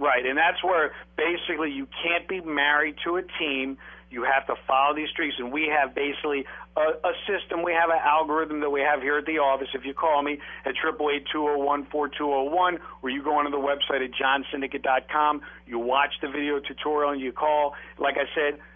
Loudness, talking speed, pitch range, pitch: -25 LUFS, 220 wpm, 140-155 Hz, 145 Hz